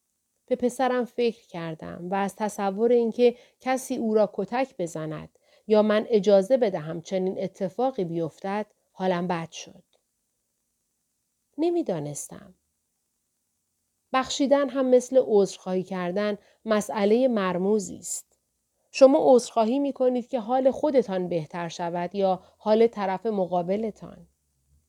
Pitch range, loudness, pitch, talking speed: 185-250 Hz, -25 LUFS, 210 Hz, 105 wpm